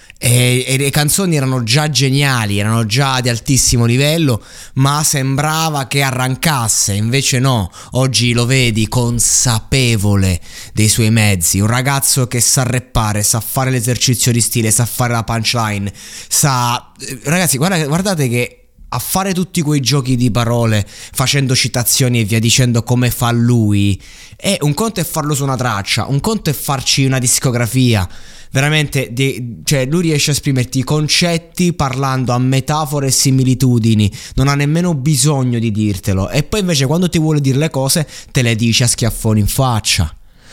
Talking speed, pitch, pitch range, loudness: 160 wpm, 130 Hz, 115-140 Hz, -14 LUFS